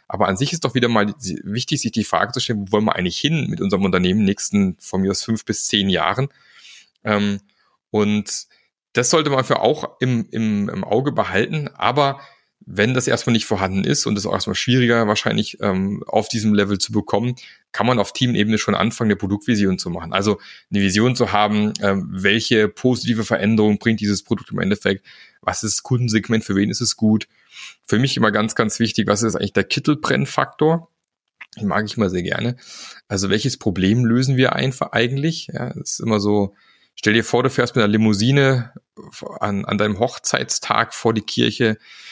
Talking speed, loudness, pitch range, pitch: 195 wpm, -19 LUFS, 100-125 Hz, 110 Hz